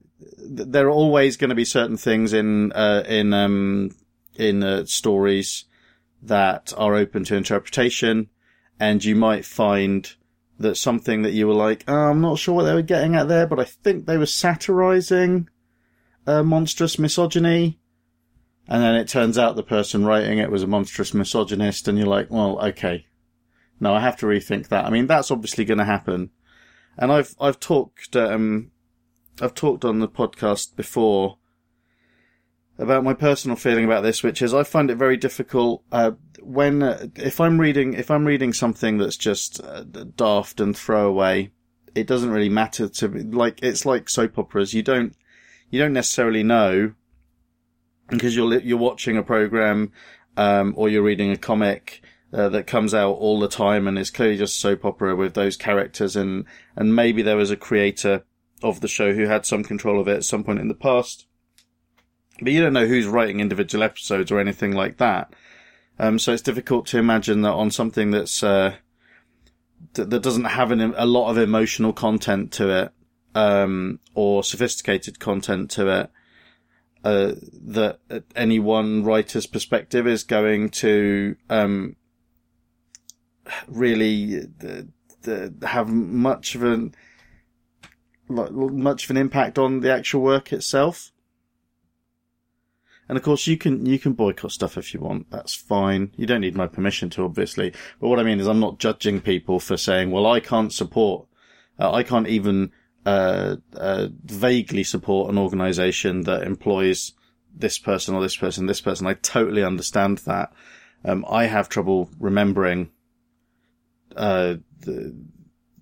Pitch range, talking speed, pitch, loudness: 95-120 Hz, 165 wpm, 105 Hz, -21 LUFS